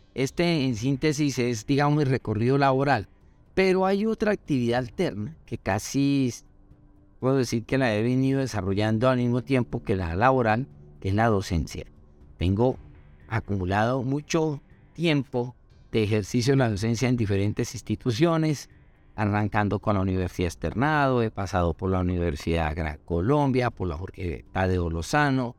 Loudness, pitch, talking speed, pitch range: -25 LUFS, 115 Hz, 150 wpm, 95-135 Hz